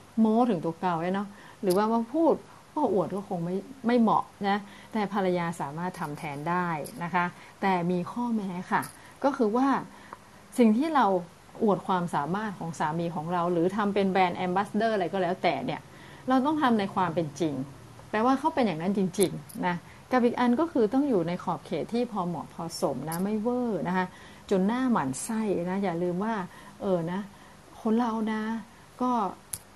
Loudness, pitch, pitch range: -28 LUFS, 190 Hz, 175-225 Hz